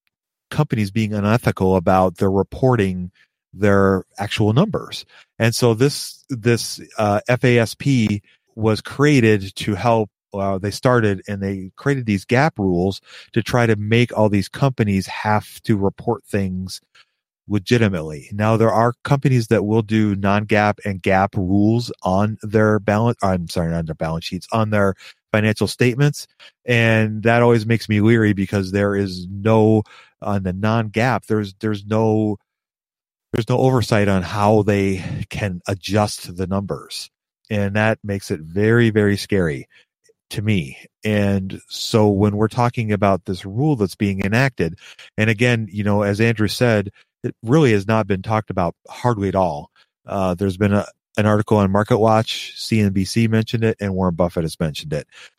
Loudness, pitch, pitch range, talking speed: -19 LUFS, 105 Hz, 100-115 Hz, 160 wpm